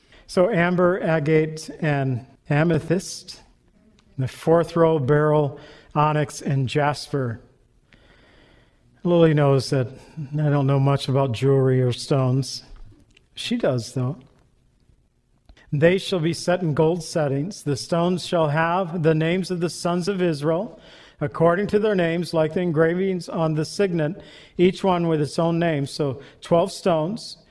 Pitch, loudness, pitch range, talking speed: 155 Hz, -22 LUFS, 140-170 Hz, 140 wpm